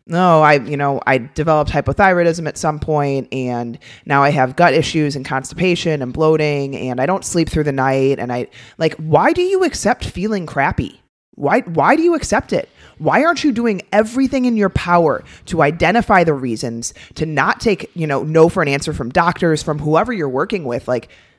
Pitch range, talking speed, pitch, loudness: 135-185 Hz, 200 wpm, 155 Hz, -16 LUFS